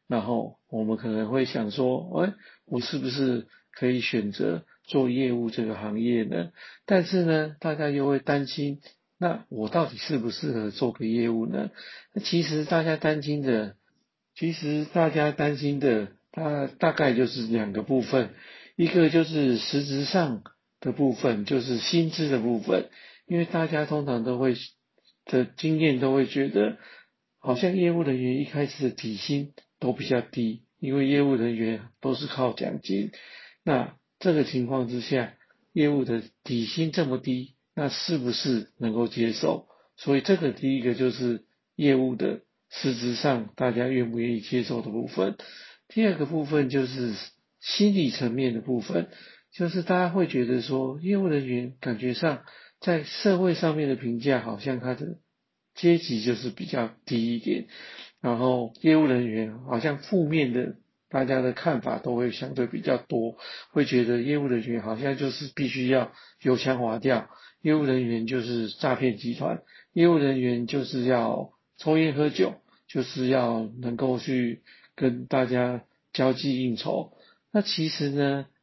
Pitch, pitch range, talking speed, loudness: 130 Hz, 120-150 Hz, 235 characters per minute, -27 LUFS